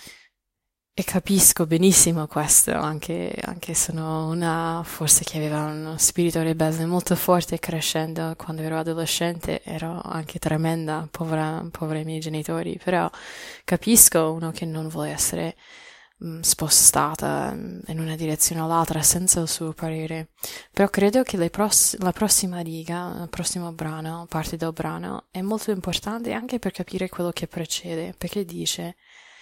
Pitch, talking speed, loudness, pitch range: 165 Hz, 145 wpm, -22 LUFS, 160-180 Hz